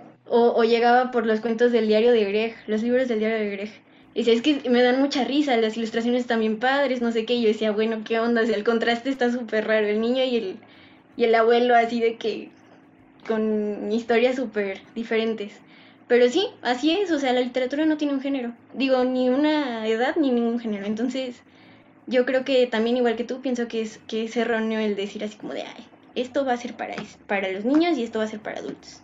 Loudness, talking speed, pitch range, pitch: -23 LUFS, 230 wpm, 225-260 Hz, 235 Hz